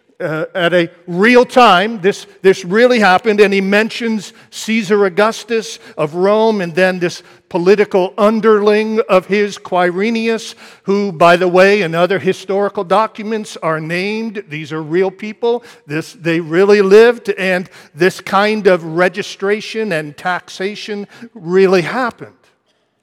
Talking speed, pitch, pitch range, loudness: 135 wpm, 200 Hz, 180-215 Hz, -14 LUFS